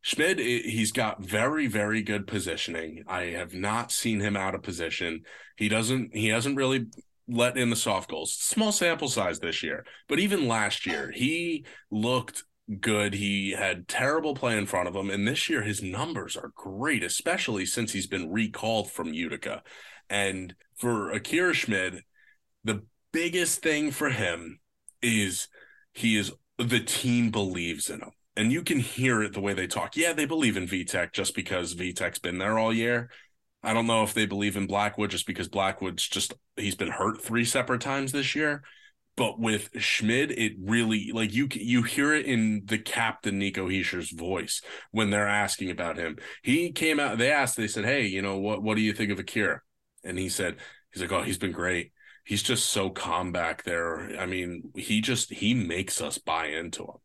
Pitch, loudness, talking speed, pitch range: 105 Hz, -28 LUFS, 190 wpm, 95-120 Hz